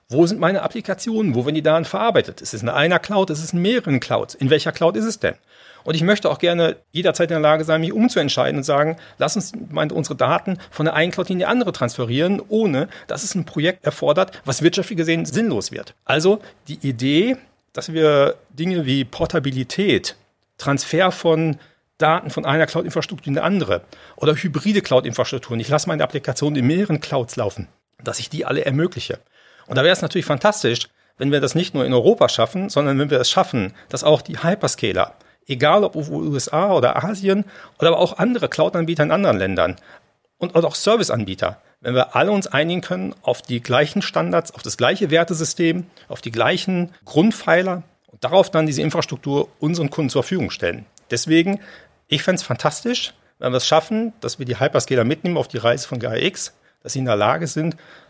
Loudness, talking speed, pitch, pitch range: -19 LUFS, 195 wpm, 160 Hz, 140-180 Hz